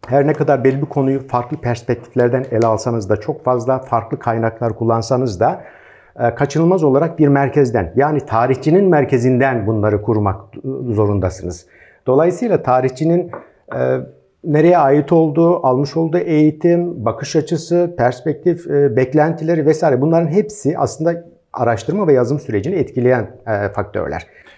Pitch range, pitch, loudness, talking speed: 115-155 Hz, 135 Hz, -16 LUFS, 120 wpm